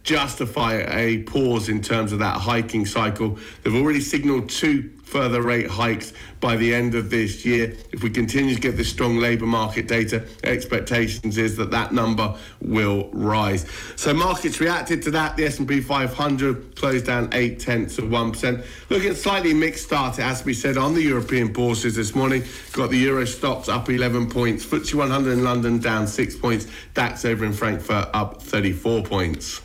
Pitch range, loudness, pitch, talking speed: 110-130 Hz, -22 LUFS, 120 Hz, 180 wpm